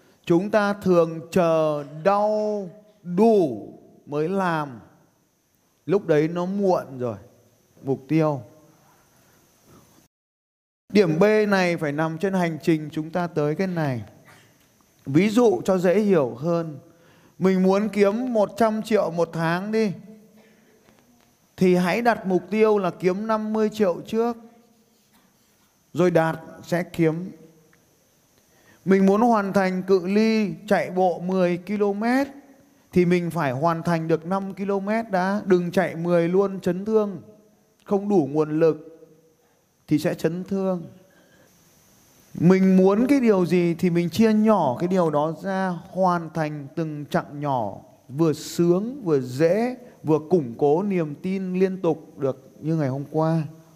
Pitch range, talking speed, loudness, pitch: 160-200 Hz, 135 wpm, -22 LUFS, 180 Hz